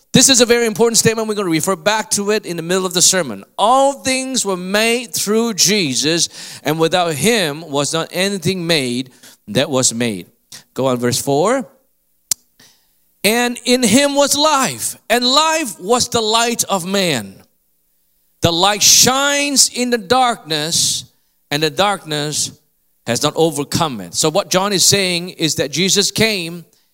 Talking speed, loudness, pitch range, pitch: 165 wpm, -15 LUFS, 150-230 Hz, 185 Hz